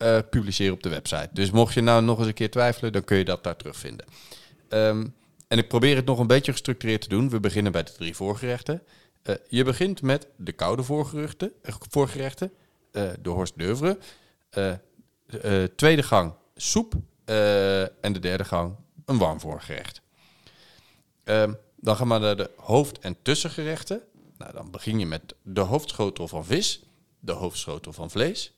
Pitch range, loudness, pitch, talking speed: 100-140 Hz, -25 LUFS, 115 Hz, 180 wpm